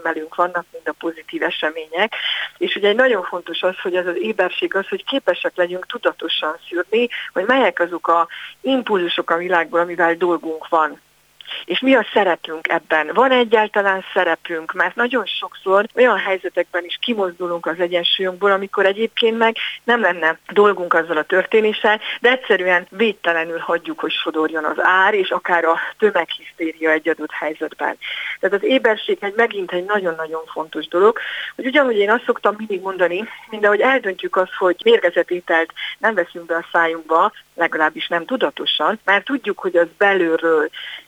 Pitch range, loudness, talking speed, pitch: 170-210 Hz, -18 LUFS, 155 wpm, 180 Hz